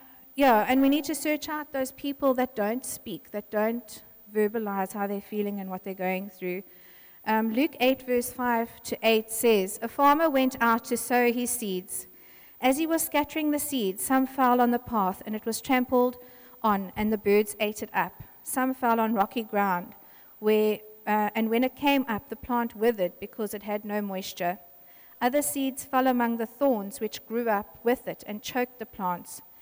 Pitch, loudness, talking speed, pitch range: 225 Hz, -27 LUFS, 195 wpm, 205-255 Hz